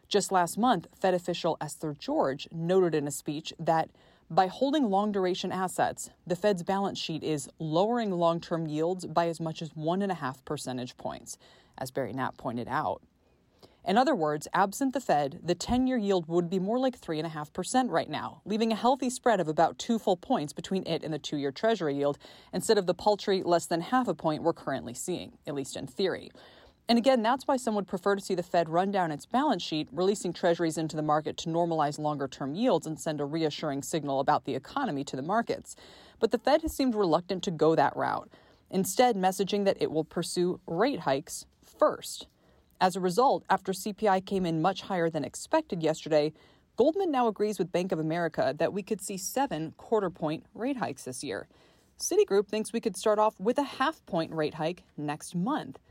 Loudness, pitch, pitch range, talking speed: -29 LUFS, 180 Hz, 155-210 Hz, 205 wpm